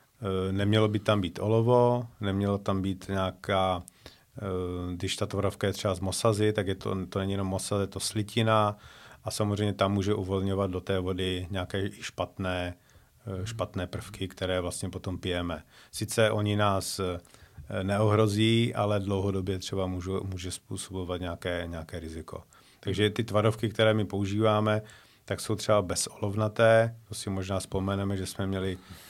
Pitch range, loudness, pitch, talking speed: 95-105 Hz, -29 LUFS, 100 Hz, 145 wpm